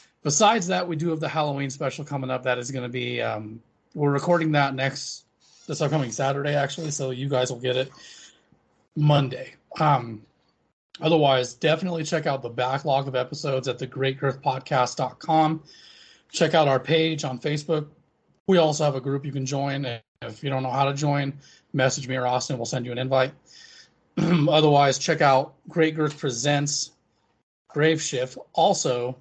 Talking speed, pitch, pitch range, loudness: 170 wpm, 140 Hz, 130-155 Hz, -24 LUFS